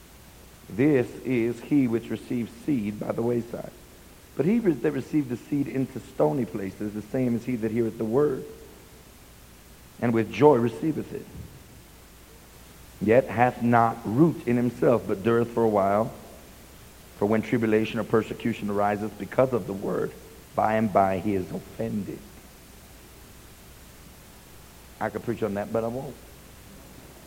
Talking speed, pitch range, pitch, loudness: 145 wpm, 105-120 Hz, 115 Hz, -26 LUFS